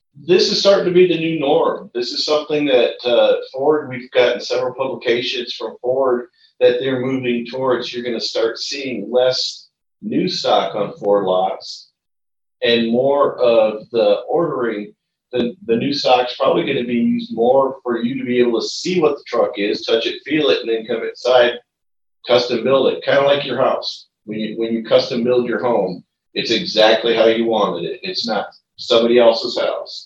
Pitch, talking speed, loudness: 130 Hz, 190 wpm, -17 LUFS